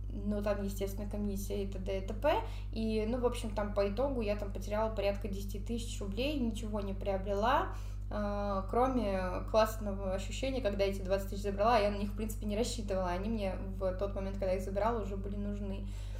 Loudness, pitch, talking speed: -35 LUFS, 105 Hz, 195 wpm